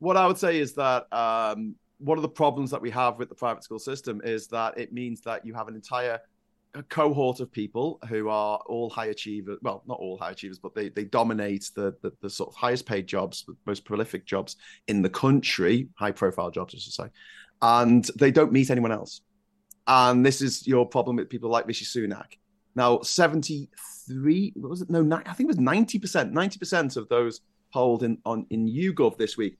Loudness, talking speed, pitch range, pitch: -26 LUFS, 210 wpm, 115-155 Hz, 125 Hz